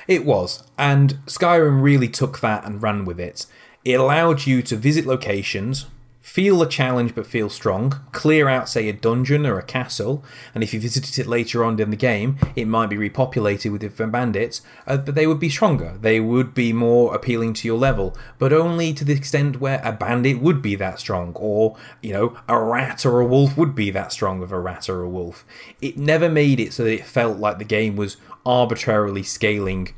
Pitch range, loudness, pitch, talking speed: 105-135 Hz, -20 LUFS, 120 Hz, 210 wpm